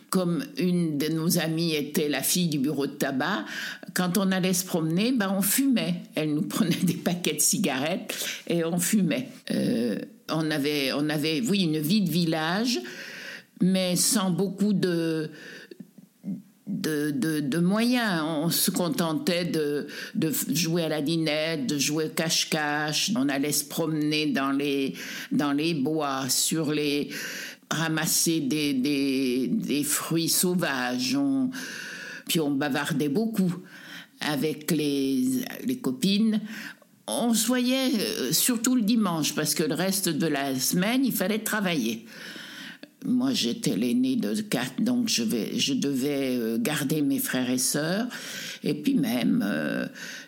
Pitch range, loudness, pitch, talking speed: 155-230 Hz, -26 LUFS, 180 Hz, 145 wpm